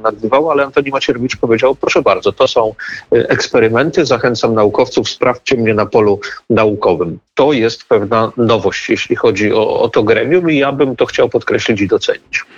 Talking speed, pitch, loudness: 165 wpm, 180 Hz, -13 LUFS